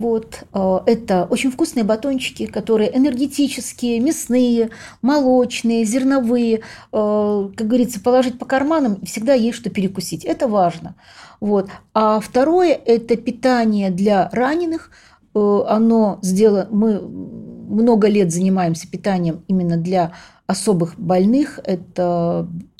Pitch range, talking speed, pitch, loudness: 190-250 Hz, 105 wpm, 220 Hz, -18 LUFS